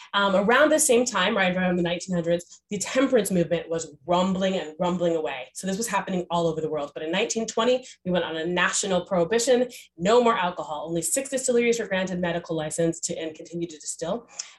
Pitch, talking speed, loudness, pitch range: 180 Hz, 200 wpm, -24 LUFS, 170-225 Hz